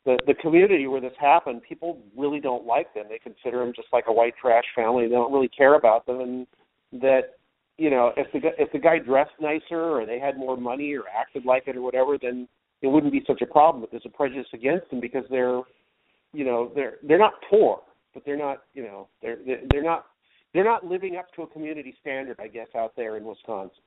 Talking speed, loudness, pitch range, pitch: 230 wpm, -23 LUFS, 120-150 Hz, 135 Hz